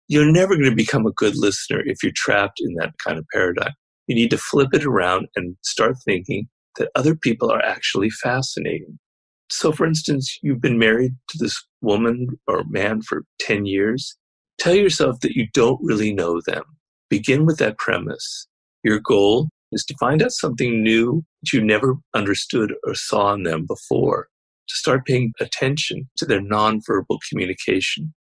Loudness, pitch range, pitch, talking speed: -20 LUFS, 110-155 Hz, 125 Hz, 175 wpm